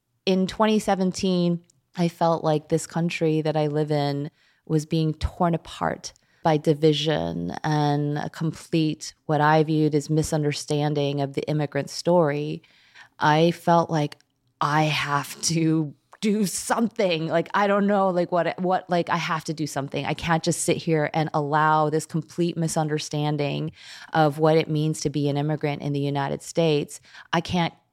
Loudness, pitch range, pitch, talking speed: -24 LUFS, 150-170 Hz, 155 Hz, 160 wpm